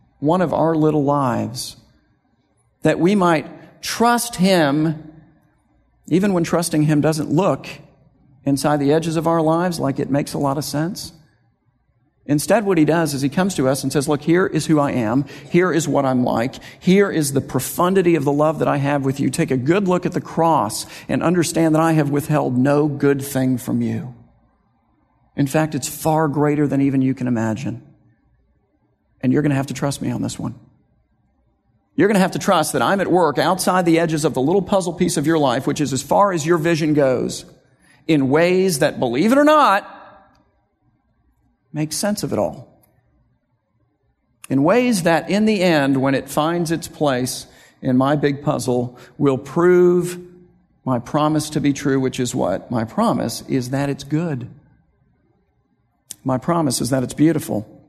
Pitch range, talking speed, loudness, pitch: 135-165 Hz, 185 wpm, -18 LUFS, 150 Hz